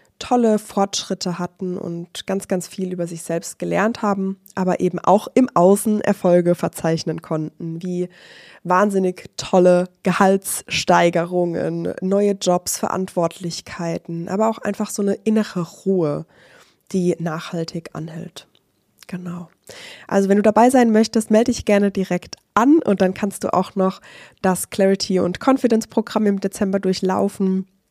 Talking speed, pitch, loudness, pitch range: 135 wpm, 190 Hz, -19 LUFS, 175-205 Hz